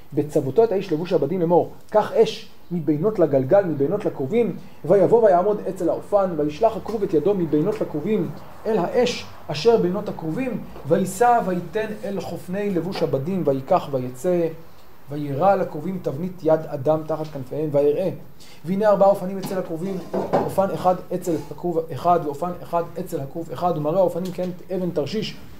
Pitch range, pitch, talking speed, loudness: 155-195 Hz, 175 Hz, 145 wpm, -22 LUFS